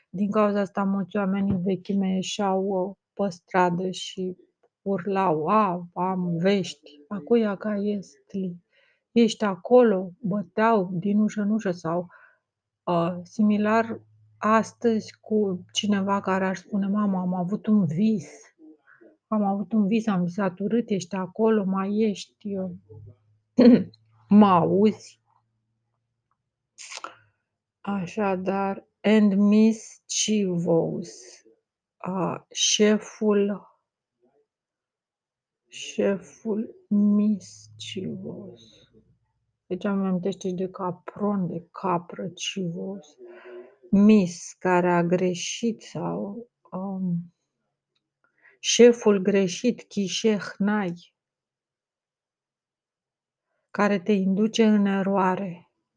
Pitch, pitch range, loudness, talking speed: 195 Hz, 180-210 Hz, -24 LUFS, 90 wpm